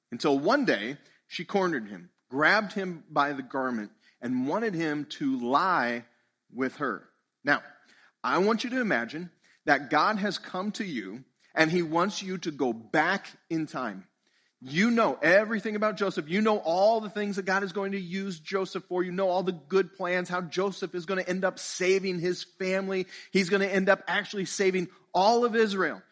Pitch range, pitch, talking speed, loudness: 165-200 Hz, 185 Hz, 190 wpm, -28 LUFS